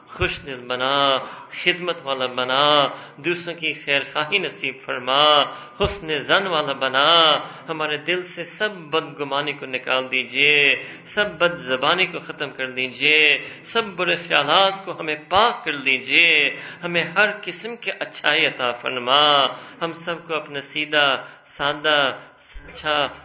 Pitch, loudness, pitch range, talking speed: 150 Hz, -19 LUFS, 140-170 Hz, 135 wpm